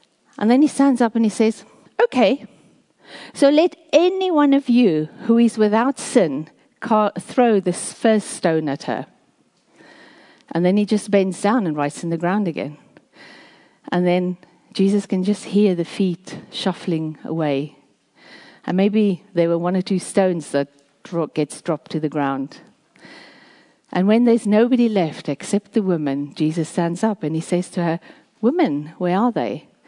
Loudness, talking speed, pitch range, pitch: -19 LUFS, 165 wpm, 170-240 Hz, 200 Hz